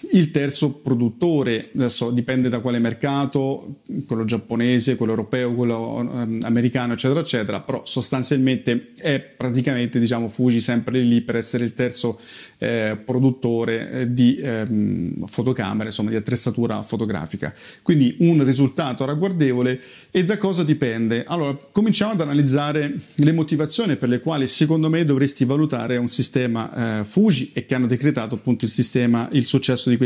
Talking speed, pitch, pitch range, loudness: 145 wpm, 125 Hz, 120-140 Hz, -20 LUFS